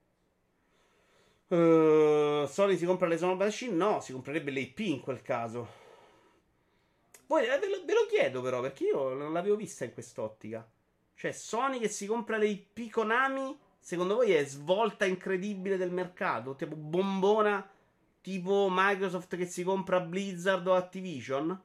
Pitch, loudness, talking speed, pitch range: 185 Hz, -30 LUFS, 145 wpm, 155-200 Hz